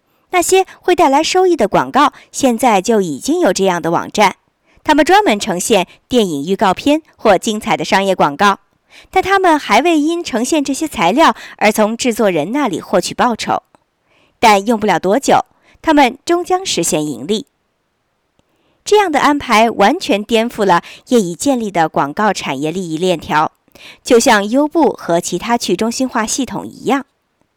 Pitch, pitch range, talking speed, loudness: 230 Hz, 195-295 Hz, 250 characters per minute, -14 LUFS